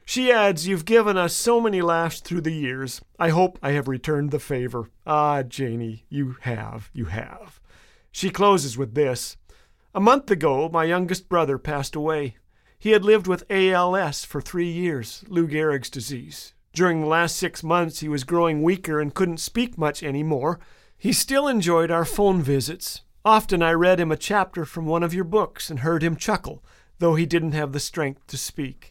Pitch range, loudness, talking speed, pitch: 145-185 Hz, -22 LUFS, 185 wpm, 165 Hz